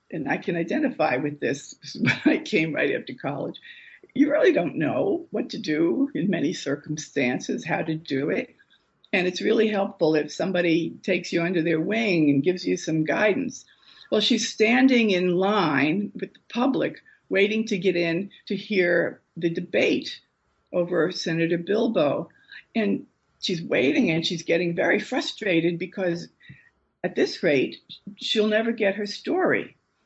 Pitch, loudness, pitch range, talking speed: 185 Hz, -24 LUFS, 170-220 Hz, 160 wpm